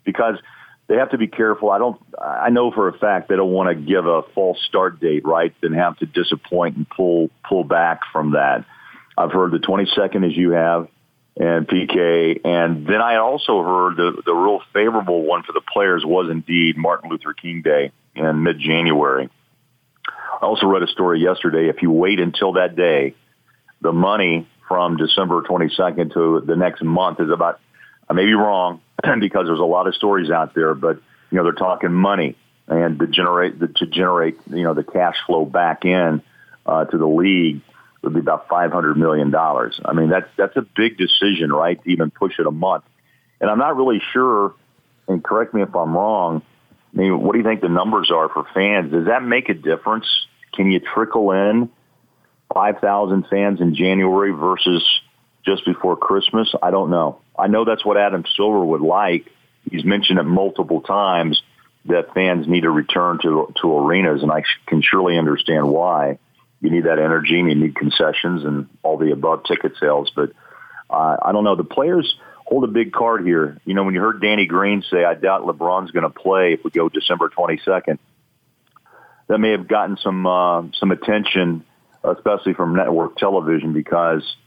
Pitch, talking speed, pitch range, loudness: 90 Hz, 195 wpm, 80-100 Hz, -18 LUFS